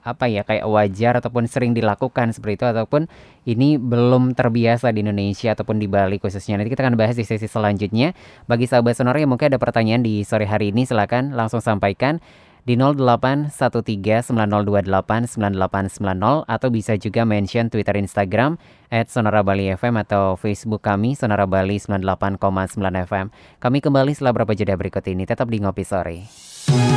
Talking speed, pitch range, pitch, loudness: 155 wpm, 100-120 Hz, 110 Hz, -19 LUFS